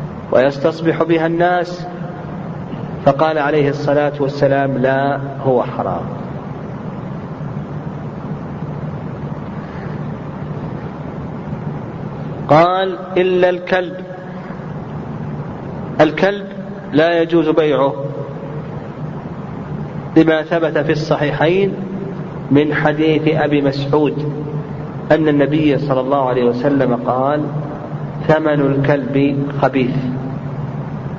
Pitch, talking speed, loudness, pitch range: 150 Hz, 65 wpm, -17 LUFS, 140-170 Hz